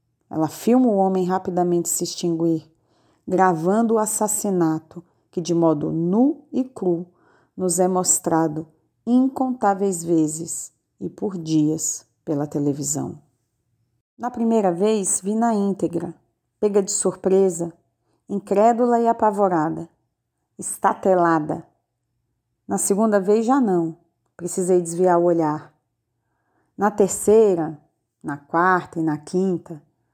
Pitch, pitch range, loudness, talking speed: 175 Hz, 155-200 Hz, -21 LUFS, 110 wpm